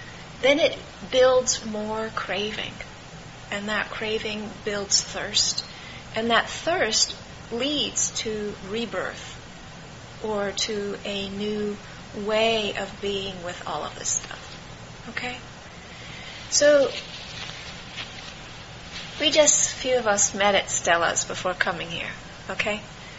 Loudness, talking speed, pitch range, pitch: -24 LUFS, 110 wpm, 205-230 Hz, 215 Hz